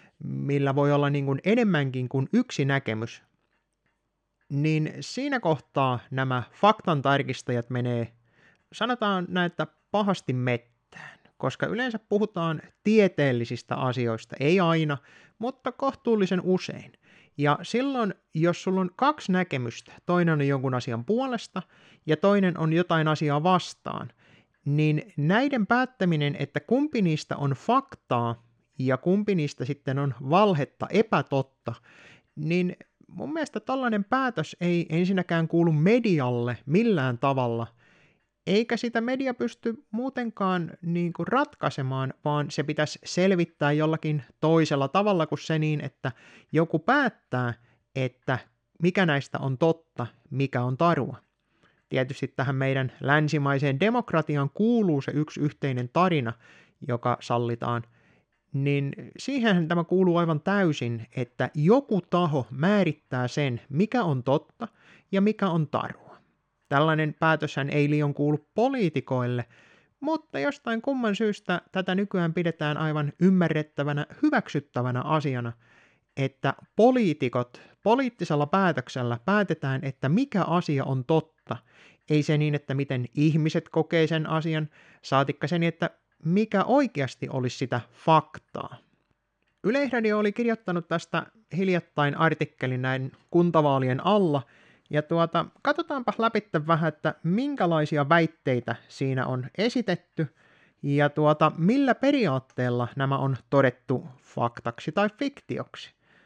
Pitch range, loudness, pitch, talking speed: 135-190 Hz, -26 LUFS, 155 Hz, 115 wpm